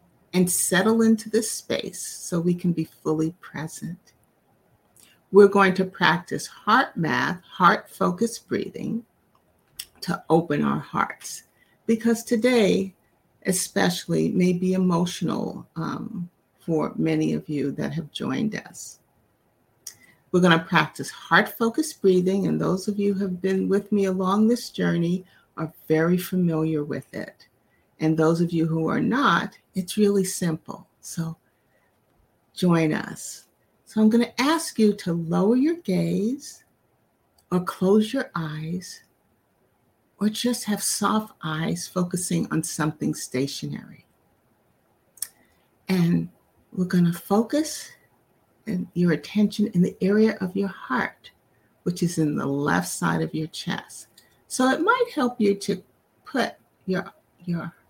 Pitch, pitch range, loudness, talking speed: 185 Hz, 165-210 Hz, -24 LUFS, 135 wpm